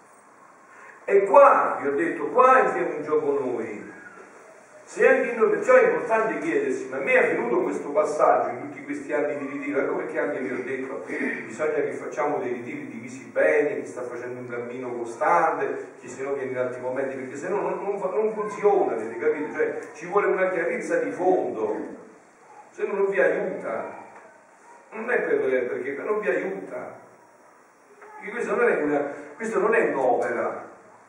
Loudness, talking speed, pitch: -24 LUFS, 170 wpm, 220 Hz